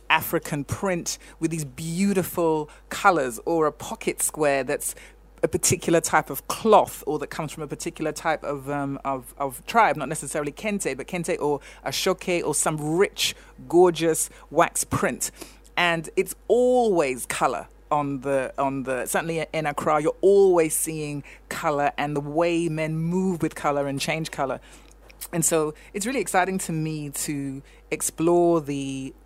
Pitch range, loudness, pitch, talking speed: 145-175 Hz, -24 LUFS, 160 Hz, 150 wpm